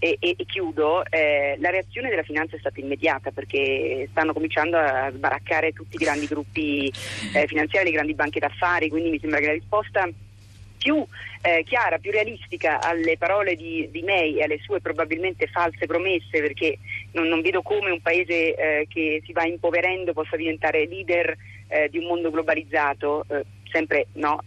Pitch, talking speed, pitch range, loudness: 160 Hz, 175 wpm, 150-175 Hz, -23 LUFS